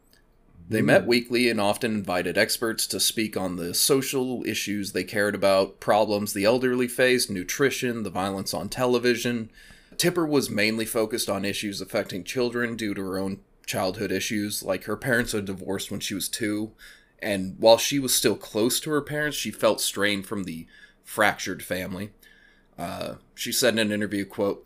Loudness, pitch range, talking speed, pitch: -25 LUFS, 100-120 Hz, 175 wpm, 105 Hz